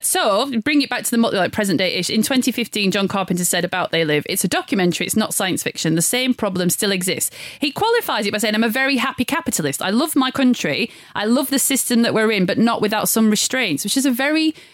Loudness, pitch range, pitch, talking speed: -18 LUFS, 190-265 Hz, 220 Hz, 250 wpm